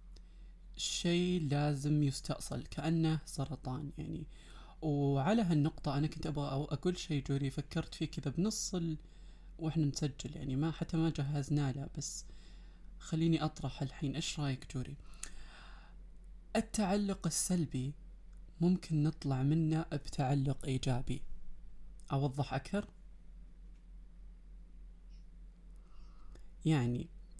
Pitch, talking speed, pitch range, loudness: 155 Hz, 90 wpm, 140-170 Hz, -36 LUFS